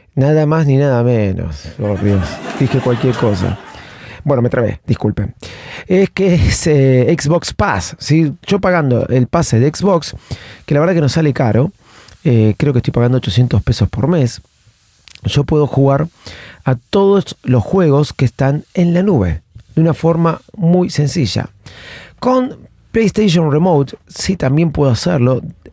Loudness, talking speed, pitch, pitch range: -14 LUFS, 155 wpm, 135 Hz, 120-165 Hz